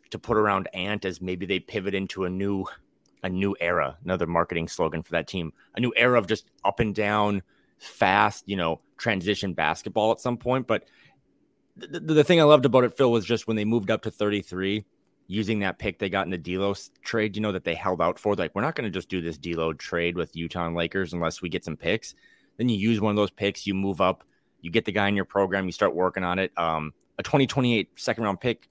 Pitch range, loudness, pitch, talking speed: 90-110 Hz, -26 LUFS, 100 Hz, 250 wpm